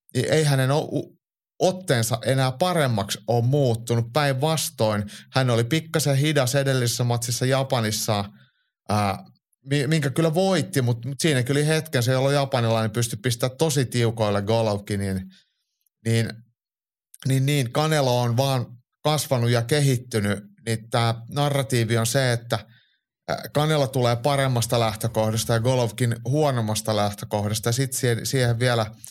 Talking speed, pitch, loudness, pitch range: 120 wpm, 125 Hz, -23 LUFS, 115-140 Hz